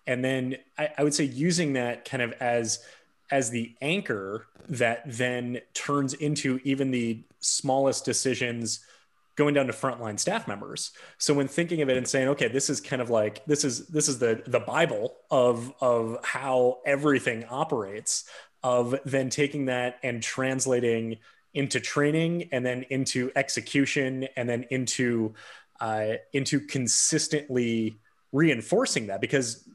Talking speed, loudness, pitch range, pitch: 150 wpm, -27 LUFS, 120-145 Hz, 130 Hz